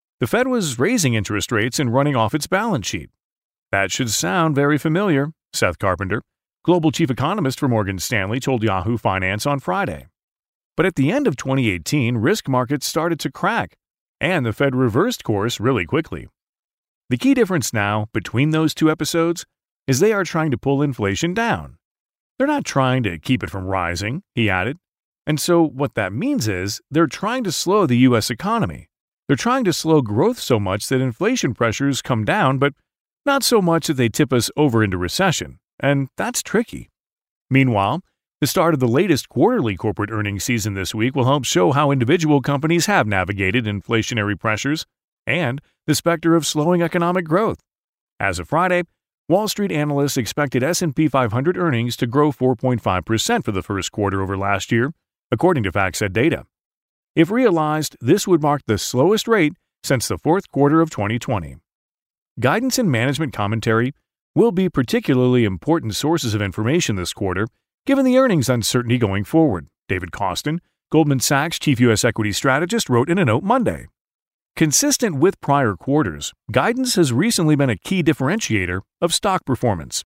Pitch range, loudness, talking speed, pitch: 110-165 Hz, -19 LUFS, 170 wpm, 135 Hz